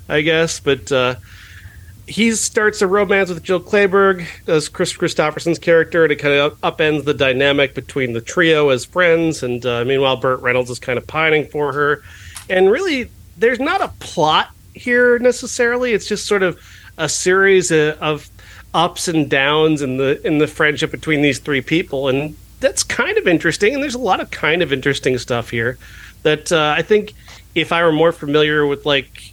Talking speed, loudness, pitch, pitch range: 185 wpm, -16 LUFS, 150 Hz, 135-180 Hz